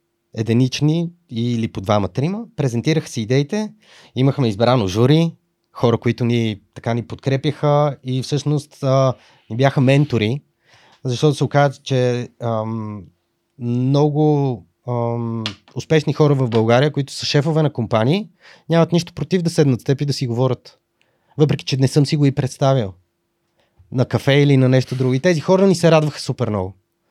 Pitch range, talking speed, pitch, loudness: 120-150 Hz, 160 wpm, 135 Hz, -18 LUFS